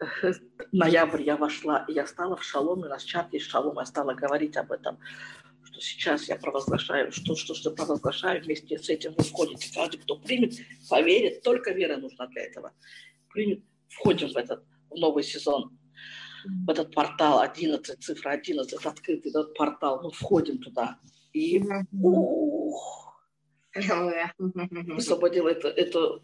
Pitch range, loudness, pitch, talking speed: 150-200 Hz, -28 LUFS, 170 Hz, 140 wpm